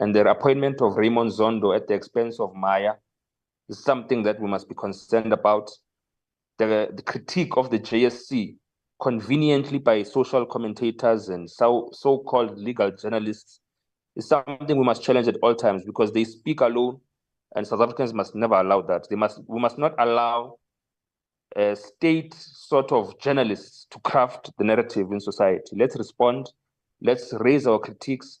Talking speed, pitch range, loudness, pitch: 160 wpm, 105-130 Hz, -23 LUFS, 120 Hz